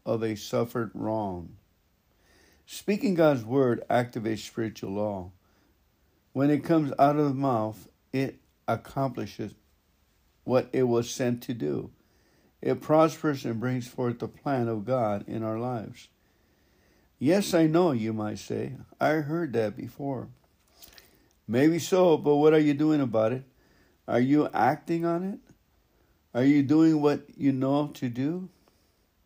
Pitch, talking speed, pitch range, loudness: 125 Hz, 140 wpm, 110-145 Hz, -27 LUFS